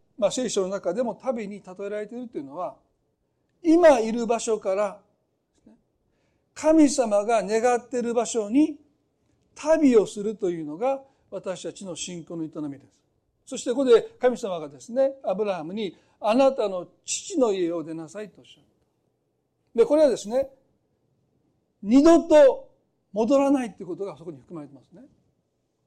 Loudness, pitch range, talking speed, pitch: -23 LUFS, 180-270 Hz, 290 characters per minute, 220 Hz